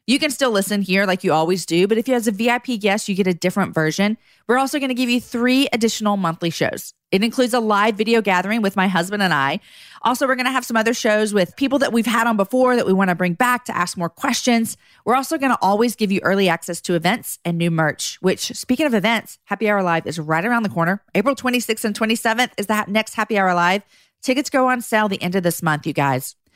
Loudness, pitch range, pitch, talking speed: -19 LUFS, 185-240 Hz, 215 Hz, 250 wpm